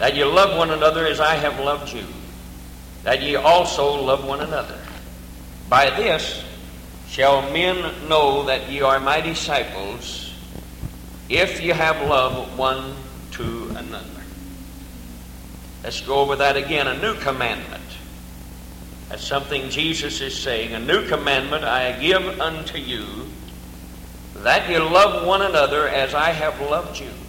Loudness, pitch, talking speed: -20 LUFS, 130 Hz, 140 wpm